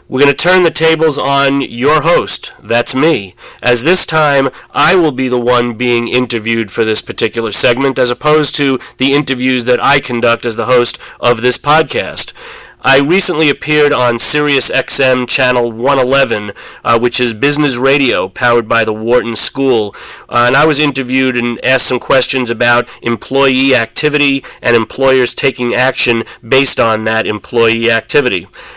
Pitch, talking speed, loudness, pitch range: 125 Hz, 165 wpm, -11 LUFS, 120-140 Hz